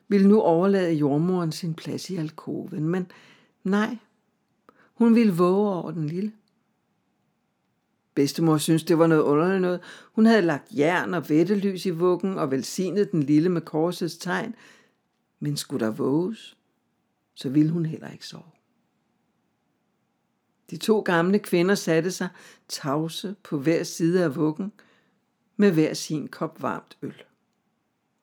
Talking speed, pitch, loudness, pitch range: 140 wpm, 180 Hz, -24 LUFS, 160-205 Hz